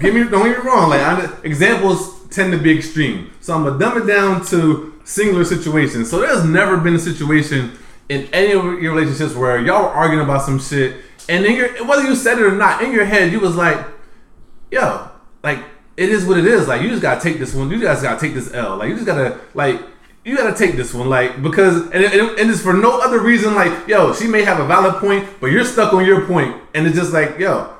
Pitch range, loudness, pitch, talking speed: 155-200 Hz, -15 LUFS, 180 Hz, 255 wpm